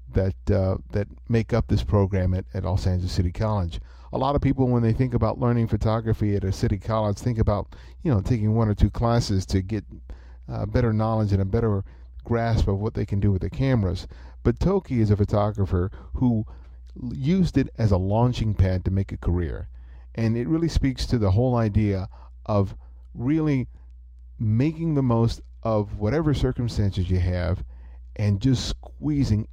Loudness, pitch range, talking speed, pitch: -24 LUFS, 90-115 Hz, 185 wpm, 105 Hz